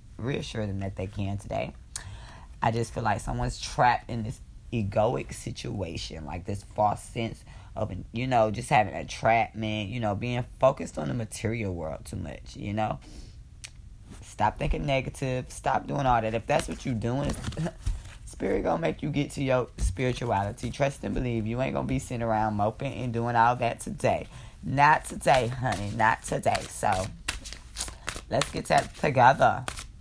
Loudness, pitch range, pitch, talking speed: -28 LUFS, 100-125 Hz, 110 Hz, 170 wpm